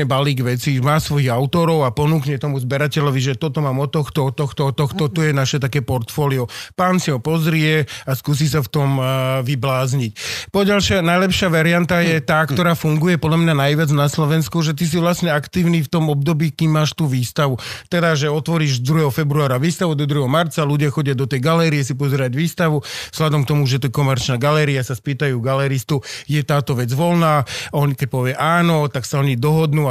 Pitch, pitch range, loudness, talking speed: 150 Hz, 135-160 Hz, -18 LUFS, 195 wpm